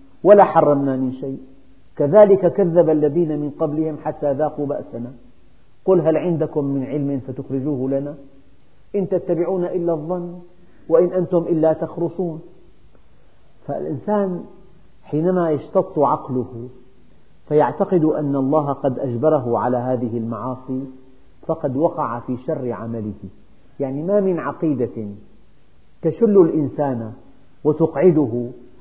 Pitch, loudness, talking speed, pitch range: 150 Hz, -19 LUFS, 105 wpm, 130-170 Hz